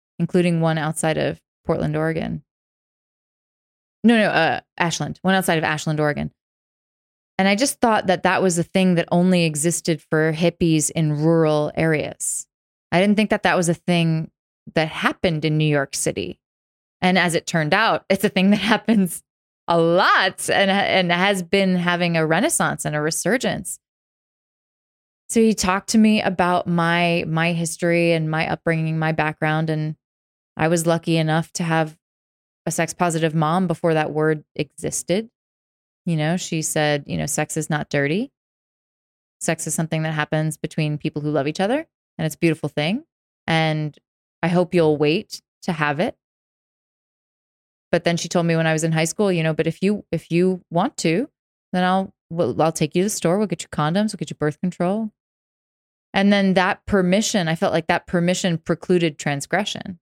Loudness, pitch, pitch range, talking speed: -20 LUFS, 170 Hz, 155-185 Hz, 180 wpm